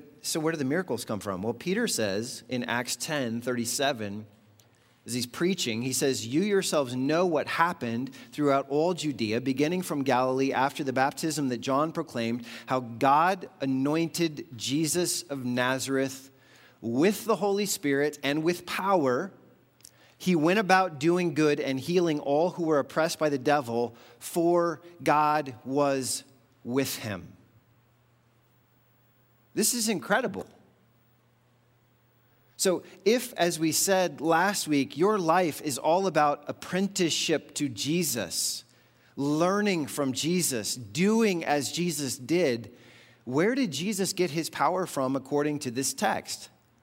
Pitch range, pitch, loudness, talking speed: 125-170 Hz, 145 Hz, -27 LUFS, 135 wpm